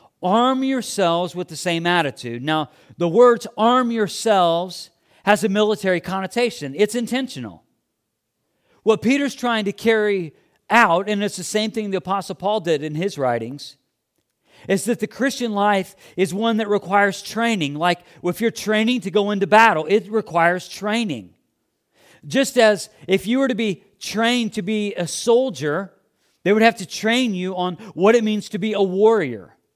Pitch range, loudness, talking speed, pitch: 175-225 Hz, -20 LUFS, 165 wpm, 205 Hz